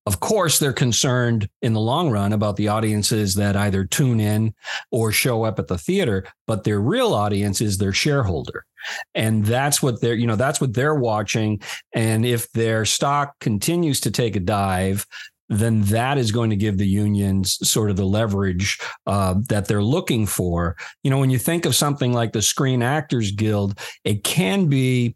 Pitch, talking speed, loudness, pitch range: 110 Hz, 190 wpm, -20 LUFS, 105-130 Hz